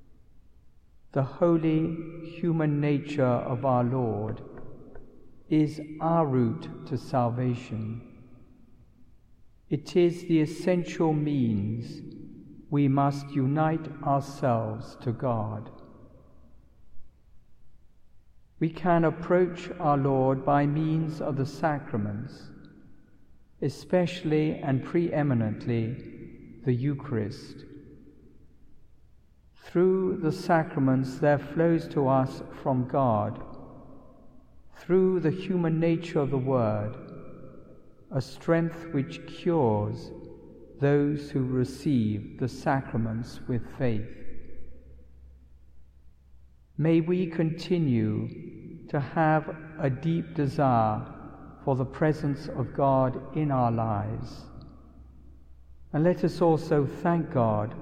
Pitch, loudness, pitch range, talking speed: 140 Hz, -27 LUFS, 115-160 Hz, 90 wpm